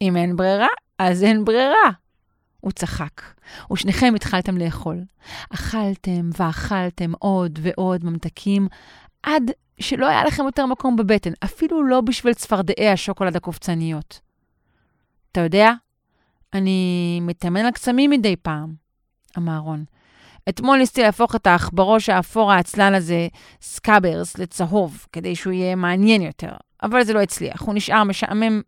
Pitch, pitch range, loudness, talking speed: 195 Hz, 175-220 Hz, -19 LUFS, 130 wpm